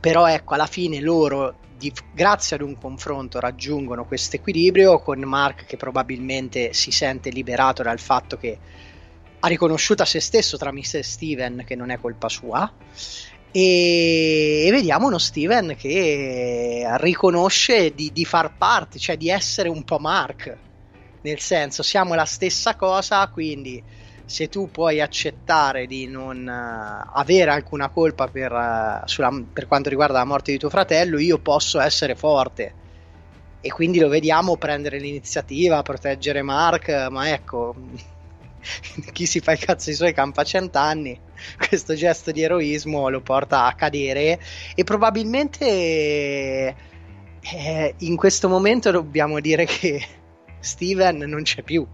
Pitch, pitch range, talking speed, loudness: 145 Hz, 125-165 Hz, 145 wpm, -20 LUFS